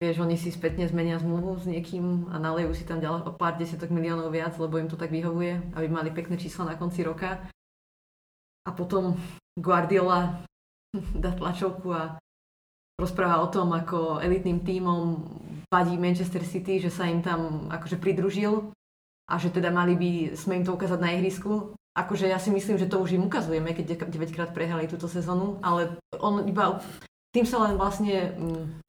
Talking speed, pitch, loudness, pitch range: 170 wpm, 175 Hz, -28 LUFS, 170-185 Hz